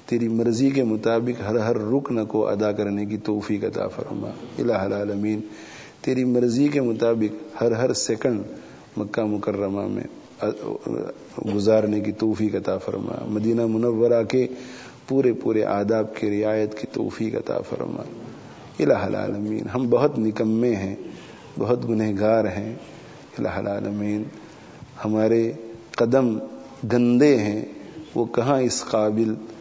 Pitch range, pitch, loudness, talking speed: 105-120 Hz, 110 Hz, -23 LUFS, 125 wpm